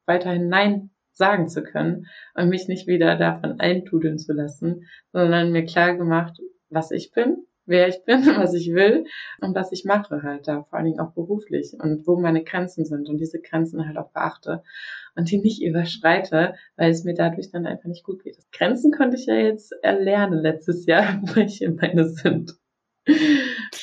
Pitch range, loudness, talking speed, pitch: 160-195 Hz, -21 LUFS, 185 wpm, 175 Hz